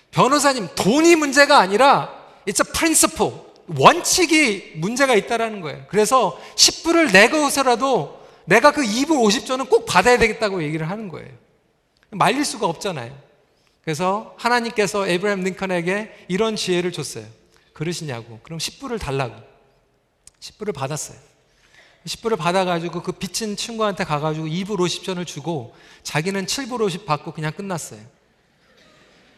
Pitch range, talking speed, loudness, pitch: 160-240 Hz, 300 characters per minute, -19 LUFS, 195 Hz